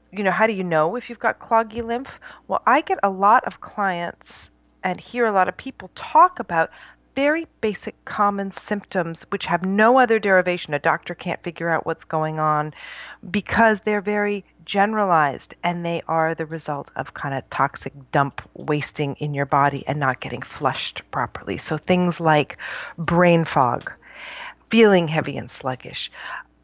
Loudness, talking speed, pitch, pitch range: -21 LUFS, 170 wpm, 185 Hz, 160-220 Hz